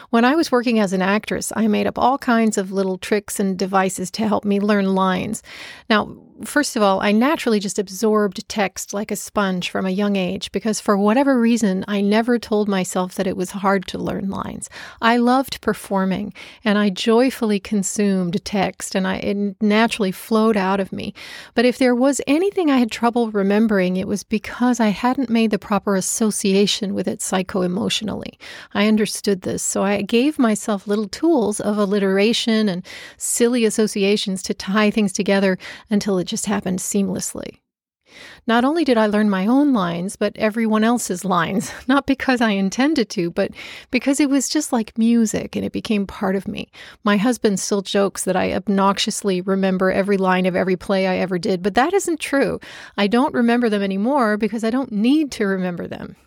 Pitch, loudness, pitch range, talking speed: 210 Hz, -19 LUFS, 195-235 Hz, 190 wpm